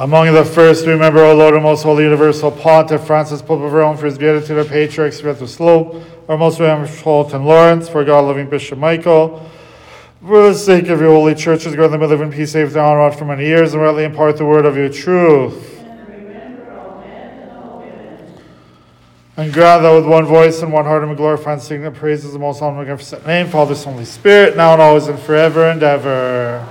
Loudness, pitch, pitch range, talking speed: -11 LUFS, 155 Hz, 150-160 Hz, 215 wpm